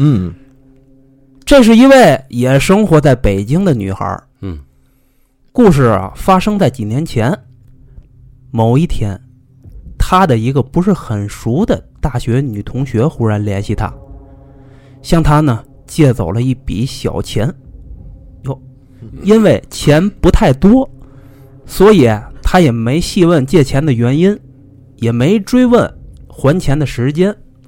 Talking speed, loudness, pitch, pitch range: 180 characters per minute, -12 LUFS, 130 Hz, 115-155 Hz